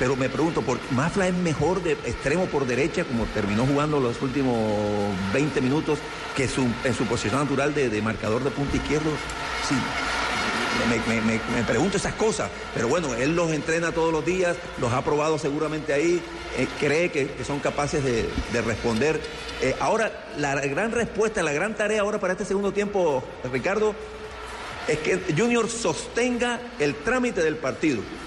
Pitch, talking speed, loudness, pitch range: 155 Hz, 175 wpm, -25 LUFS, 135-195 Hz